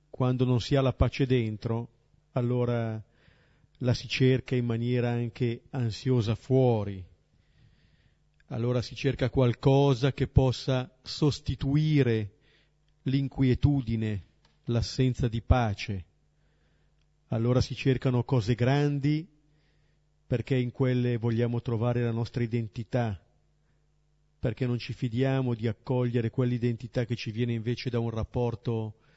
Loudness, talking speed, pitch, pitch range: -28 LUFS, 110 wpm, 125 Hz, 115-130 Hz